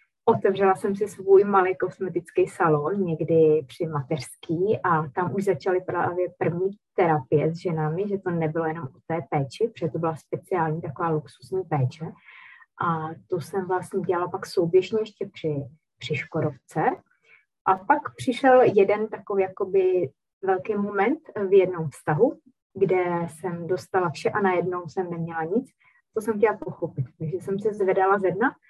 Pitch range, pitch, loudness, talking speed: 160-195 Hz, 180 Hz, -25 LUFS, 155 wpm